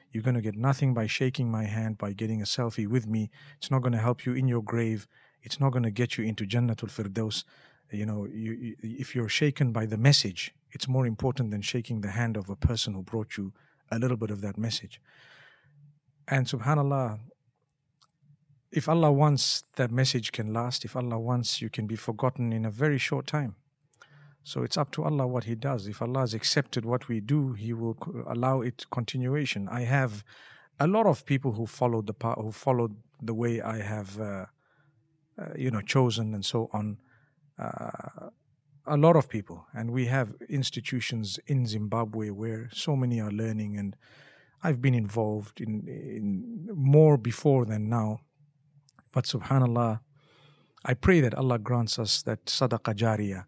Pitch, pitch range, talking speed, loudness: 120 Hz, 110-140 Hz, 185 wpm, -29 LUFS